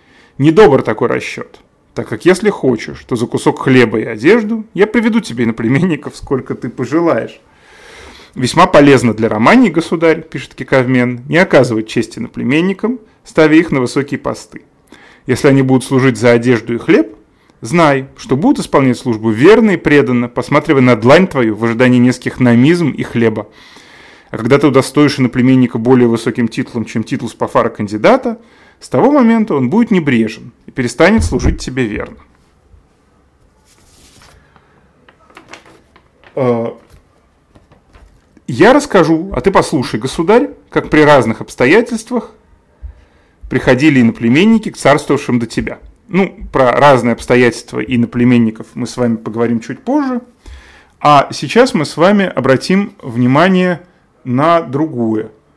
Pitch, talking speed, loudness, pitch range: 130 Hz, 135 wpm, -12 LUFS, 115-165 Hz